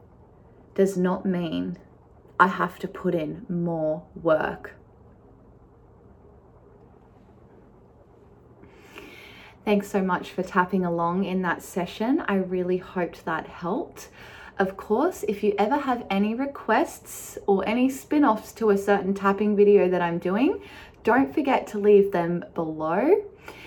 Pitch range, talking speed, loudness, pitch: 180-215 Hz, 125 wpm, -24 LUFS, 195 Hz